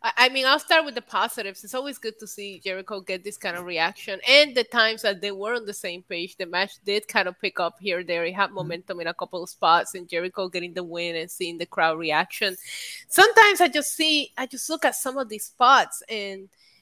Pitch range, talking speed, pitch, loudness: 180-245 Hz, 245 wpm, 200 Hz, -23 LUFS